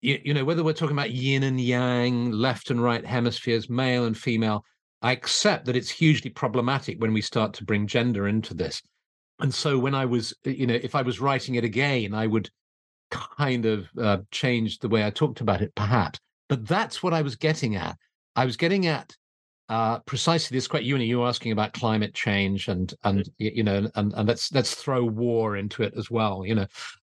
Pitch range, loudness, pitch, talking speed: 110-130 Hz, -25 LUFS, 120 Hz, 210 wpm